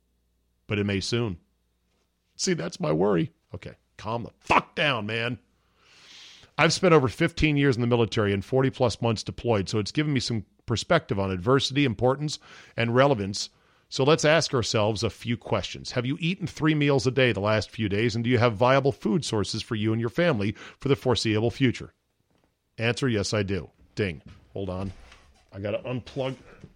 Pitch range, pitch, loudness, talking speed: 100-130 Hz, 115 Hz, -25 LUFS, 185 wpm